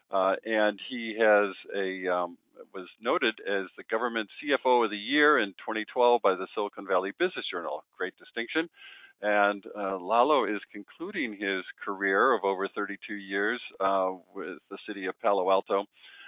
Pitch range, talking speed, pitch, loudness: 95-115 Hz, 160 wpm, 105 Hz, -28 LUFS